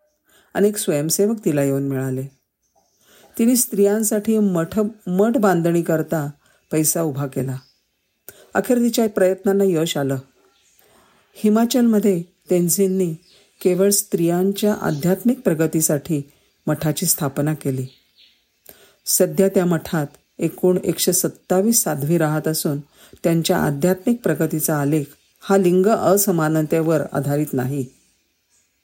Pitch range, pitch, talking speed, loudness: 145-195 Hz, 170 Hz, 95 wpm, -19 LUFS